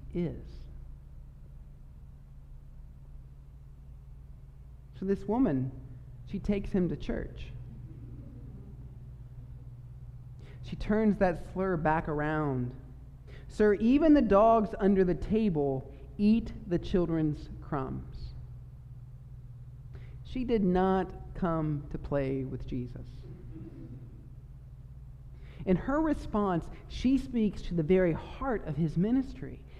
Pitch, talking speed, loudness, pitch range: 130 Hz, 95 wpm, -30 LUFS, 125-185 Hz